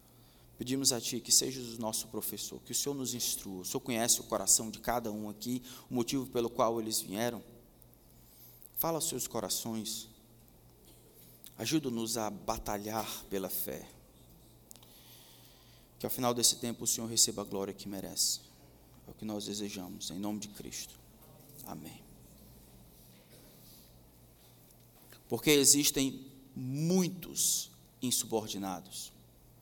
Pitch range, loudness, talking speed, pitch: 100-125 Hz, -32 LUFS, 130 wpm, 115 Hz